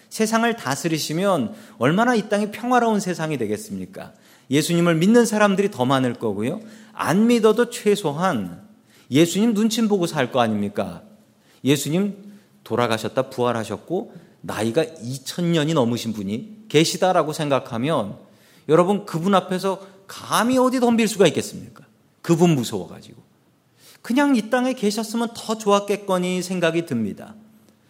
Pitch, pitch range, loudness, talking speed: 185 Hz, 140-220 Hz, -21 LUFS, 310 characters per minute